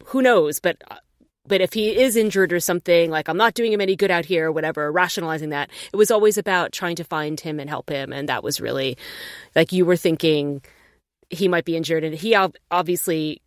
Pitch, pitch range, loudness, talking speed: 175 Hz, 155-195 Hz, -20 LUFS, 225 wpm